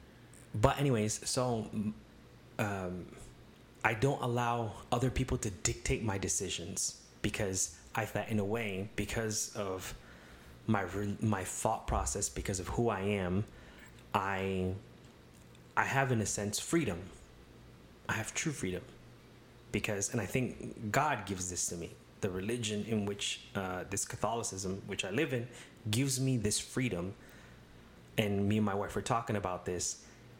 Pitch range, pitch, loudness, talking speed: 95-120 Hz, 105 Hz, -35 LUFS, 145 wpm